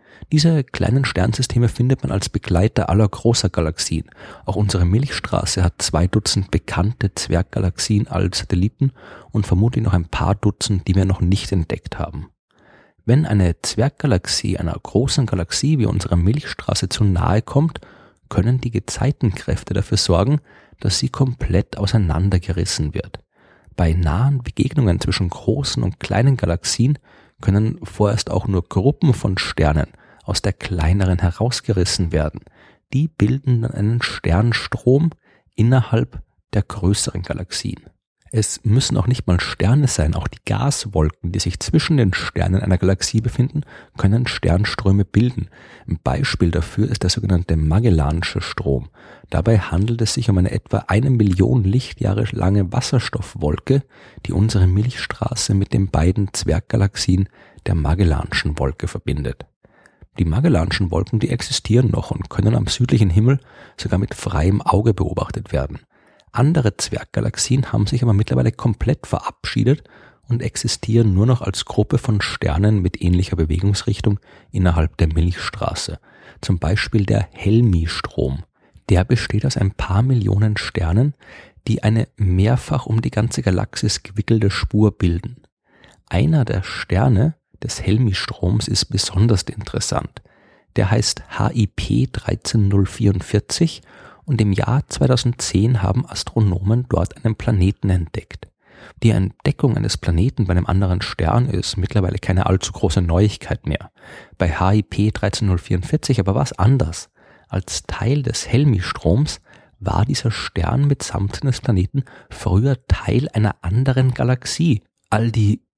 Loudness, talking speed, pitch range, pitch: -19 LUFS, 130 wpm, 95-120 Hz, 105 Hz